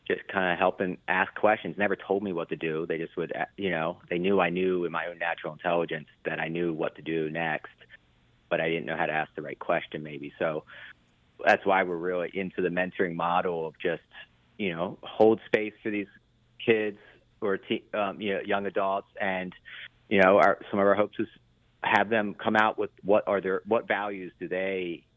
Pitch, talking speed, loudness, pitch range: 90 Hz, 210 wpm, -28 LUFS, 80-100 Hz